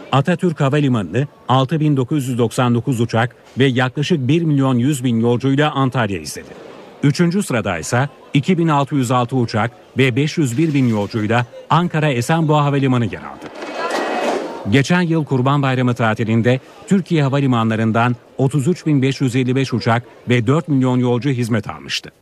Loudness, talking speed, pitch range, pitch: -17 LUFS, 105 wpm, 120-150 Hz, 130 Hz